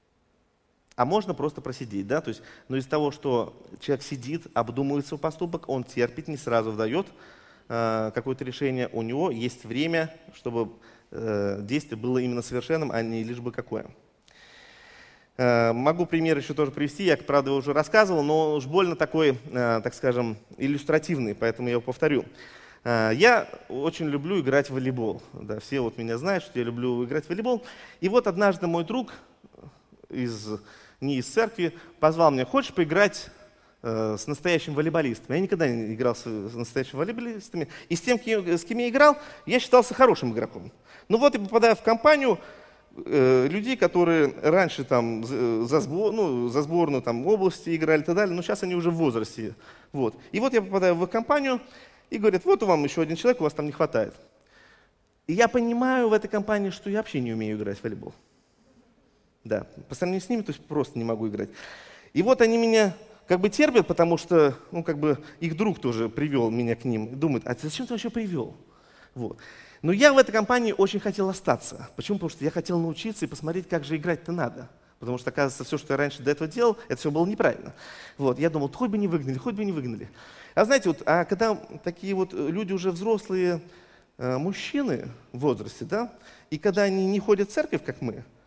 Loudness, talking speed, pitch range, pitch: -25 LUFS, 190 wpm, 125-195 Hz, 155 Hz